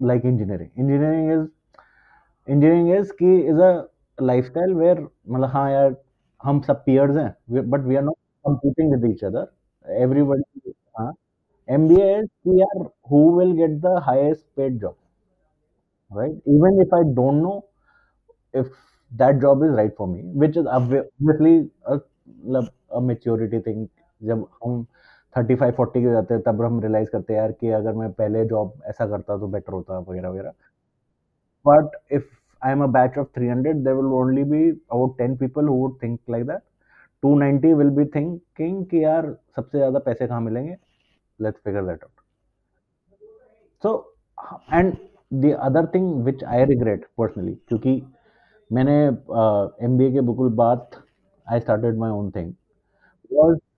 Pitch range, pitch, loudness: 120-155 Hz, 135 Hz, -20 LUFS